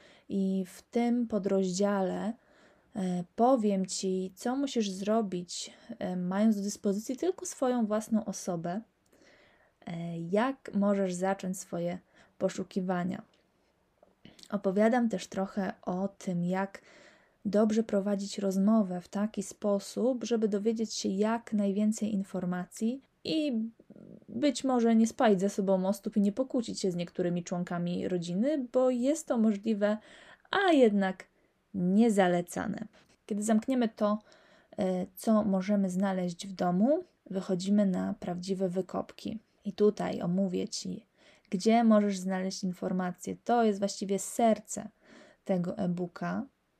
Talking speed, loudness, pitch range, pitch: 115 wpm, -31 LUFS, 190-225 Hz, 205 Hz